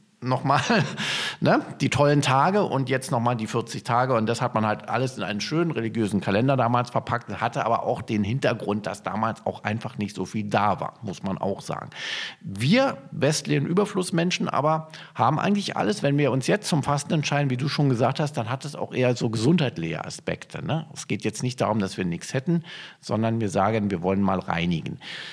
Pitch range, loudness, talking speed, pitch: 110-150 Hz, -25 LUFS, 205 wpm, 130 Hz